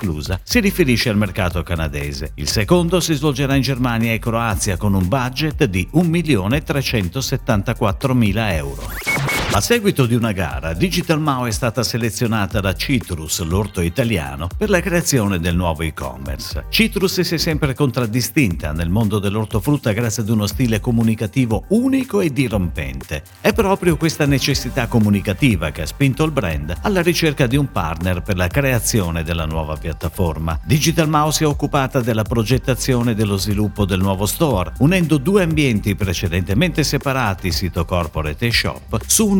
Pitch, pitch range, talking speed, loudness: 115 Hz, 95-145 Hz, 155 wpm, -18 LUFS